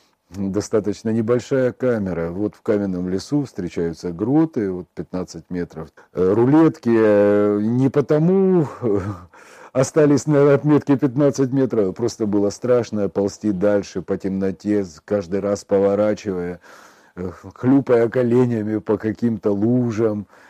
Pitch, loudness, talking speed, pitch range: 105 Hz, -19 LUFS, 100 wpm, 100-125 Hz